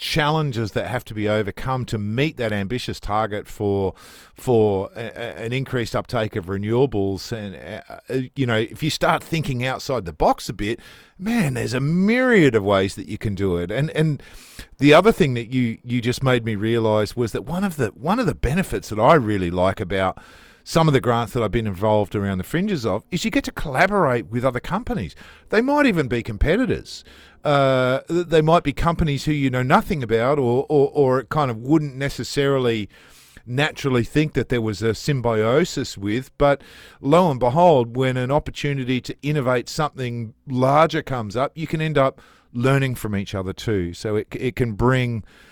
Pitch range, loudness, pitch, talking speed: 110-150 Hz, -21 LUFS, 125 Hz, 195 wpm